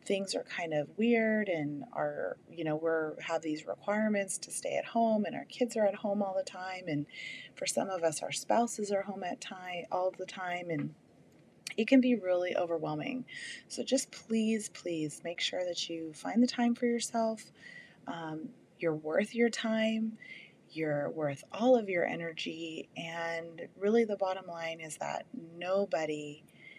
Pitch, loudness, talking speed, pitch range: 185 Hz, -34 LUFS, 175 wpm, 165-220 Hz